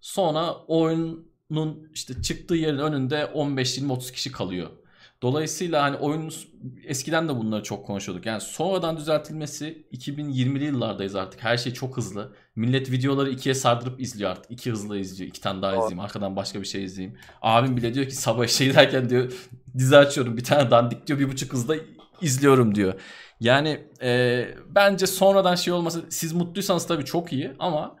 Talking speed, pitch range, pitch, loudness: 165 wpm, 120-155 Hz, 135 Hz, -24 LUFS